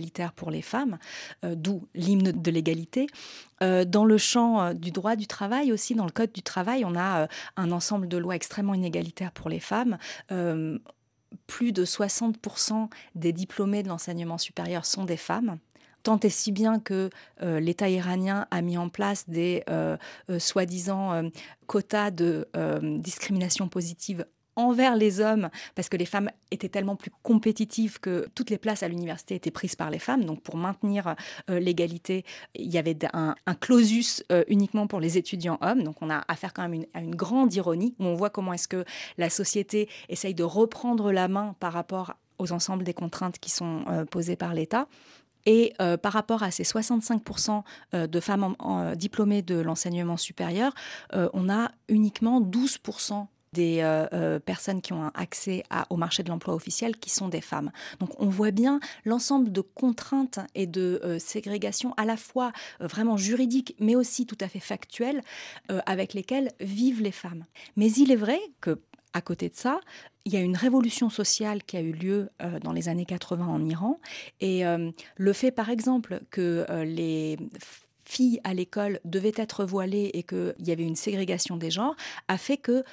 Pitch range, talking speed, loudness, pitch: 175-220 Hz, 190 wpm, -27 LUFS, 195 Hz